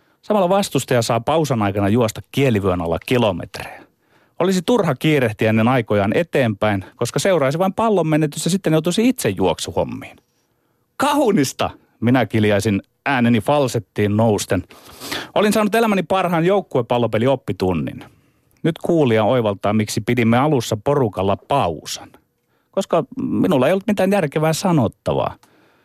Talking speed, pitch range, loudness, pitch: 120 wpm, 110-165 Hz, -18 LUFS, 130 Hz